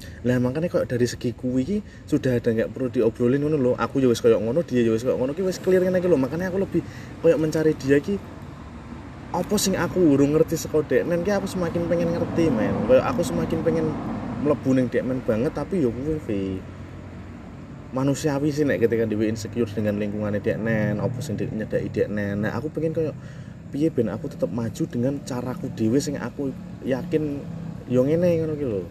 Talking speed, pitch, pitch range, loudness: 160 wpm, 135 Hz, 115-160 Hz, -23 LUFS